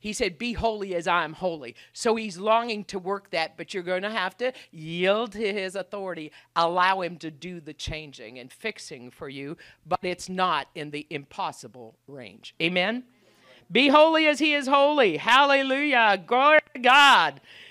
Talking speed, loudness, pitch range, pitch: 175 wpm, -23 LUFS, 170-235 Hz, 190 Hz